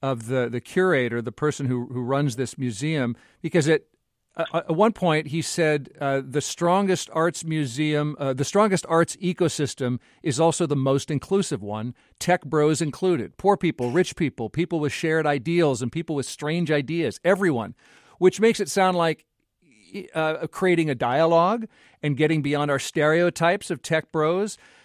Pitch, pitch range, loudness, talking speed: 155 Hz, 140-175 Hz, -23 LUFS, 165 wpm